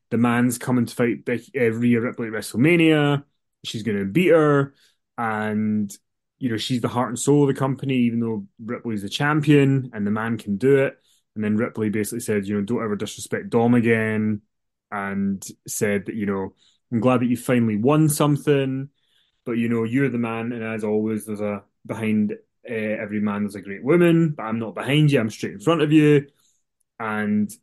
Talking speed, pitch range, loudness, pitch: 200 wpm, 105-135 Hz, -22 LUFS, 115 Hz